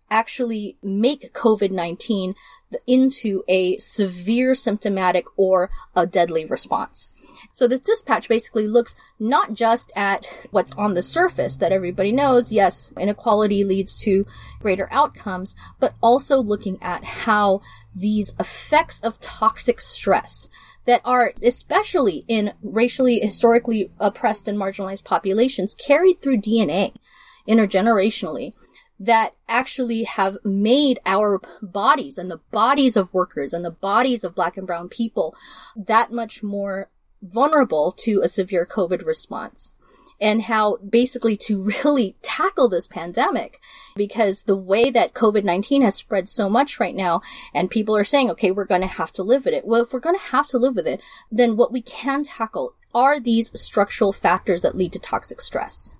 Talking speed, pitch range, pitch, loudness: 150 wpm, 195-245 Hz, 215 Hz, -20 LUFS